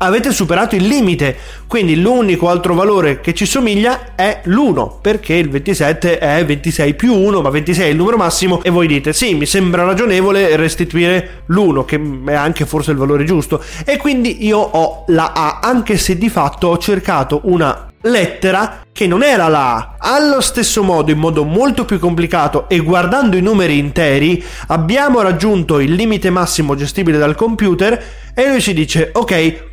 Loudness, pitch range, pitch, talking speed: -13 LUFS, 160-210 Hz, 180 Hz, 175 wpm